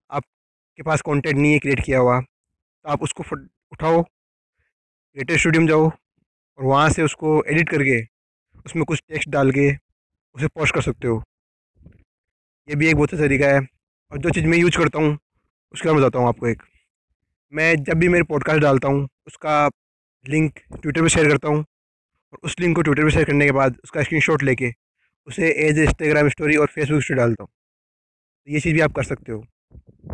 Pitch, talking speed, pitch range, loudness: 150 Hz, 195 wpm, 130-155 Hz, -19 LUFS